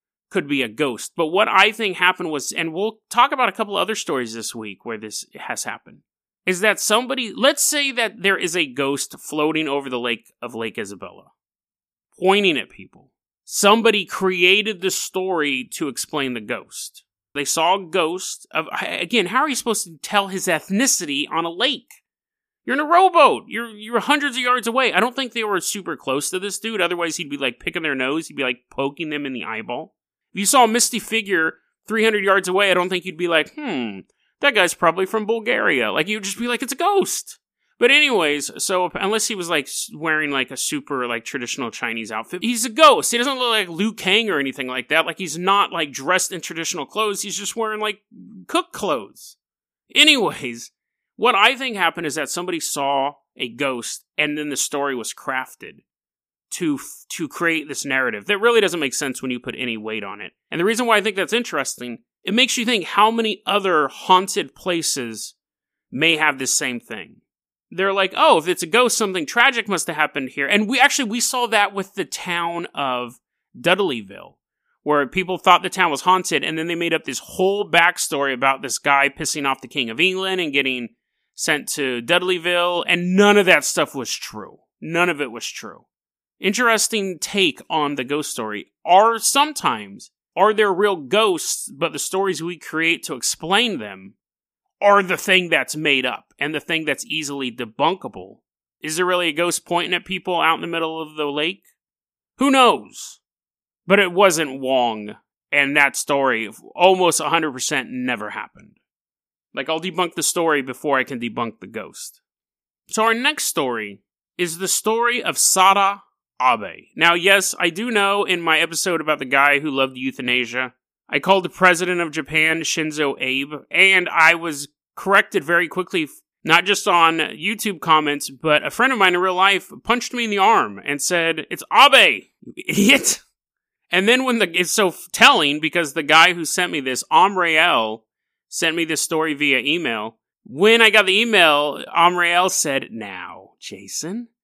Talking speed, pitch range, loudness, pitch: 190 wpm, 145-210 Hz, -18 LUFS, 175 Hz